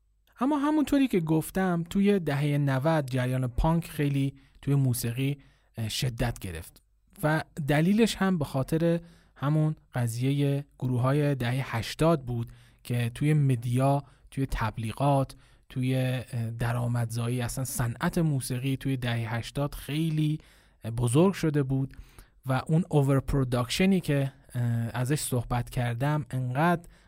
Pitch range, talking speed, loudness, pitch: 125-155 Hz, 115 wpm, -28 LUFS, 135 Hz